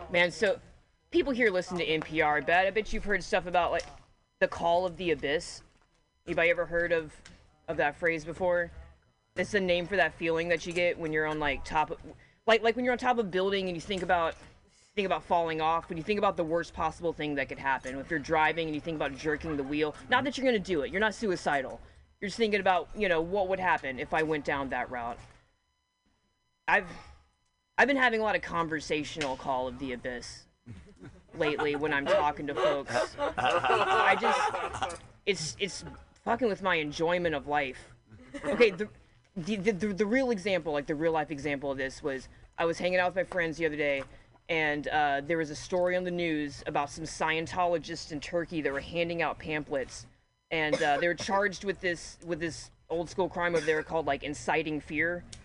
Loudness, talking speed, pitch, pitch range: -30 LUFS, 210 wpm, 165 Hz, 150-185 Hz